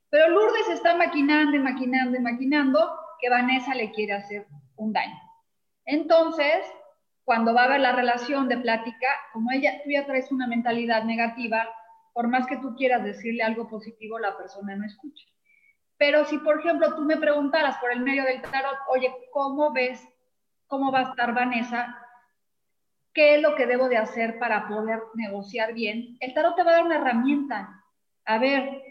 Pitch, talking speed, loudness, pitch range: 255 Hz, 175 wpm, -24 LUFS, 230-295 Hz